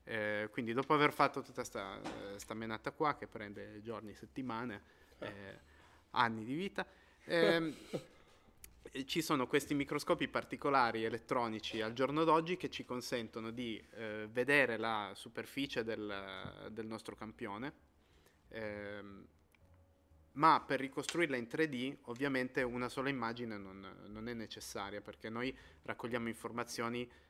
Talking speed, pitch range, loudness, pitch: 130 wpm, 105-135 Hz, -38 LUFS, 115 Hz